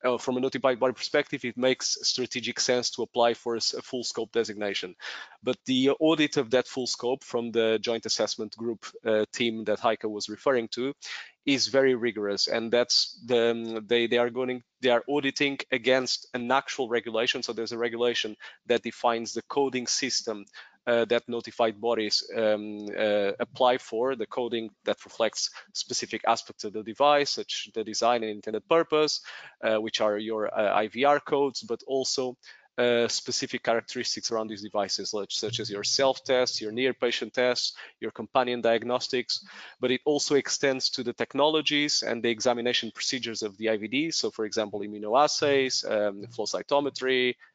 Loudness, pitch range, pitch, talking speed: -27 LUFS, 110-130 Hz, 120 Hz, 165 wpm